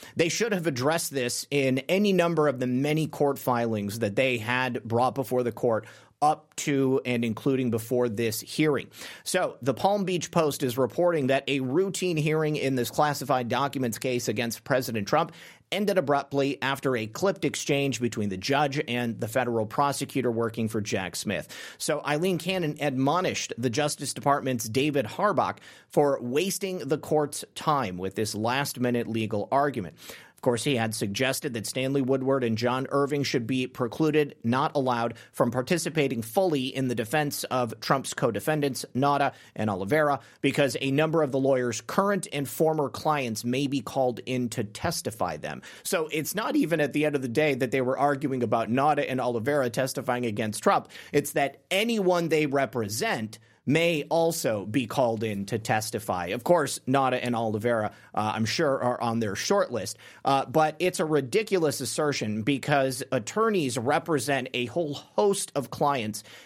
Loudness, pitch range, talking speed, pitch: -27 LUFS, 120-150 Hz, 170 wpm, 135 Hz